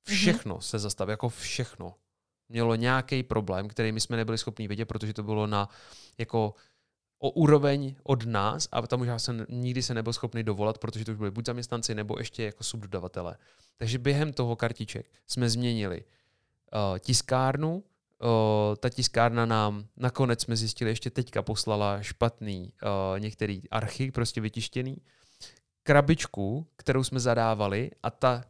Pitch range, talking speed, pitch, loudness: 105-125 Hz, 150 wpm, 115 Hz, -29 LUFS